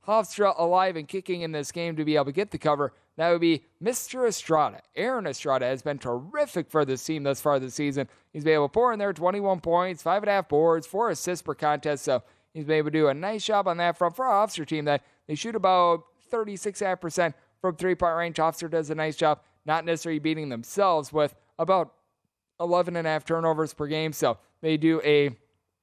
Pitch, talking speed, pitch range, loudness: 160 Hz, 220 wpm, 150-185 Hz, -26 LUFS